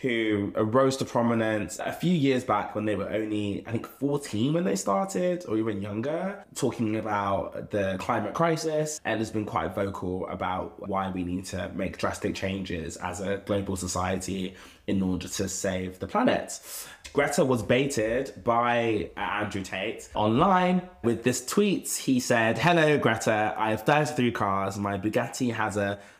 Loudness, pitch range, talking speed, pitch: -27 LUFS, 95-120 Hz, 165 wpm, 105 Hz